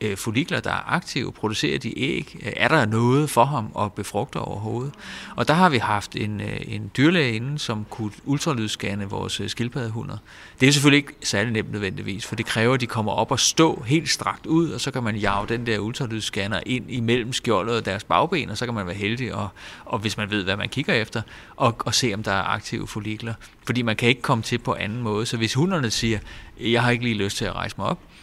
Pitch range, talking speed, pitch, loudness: 105-125 Hz, 230 wpm, 115 Hz, -23 LUFS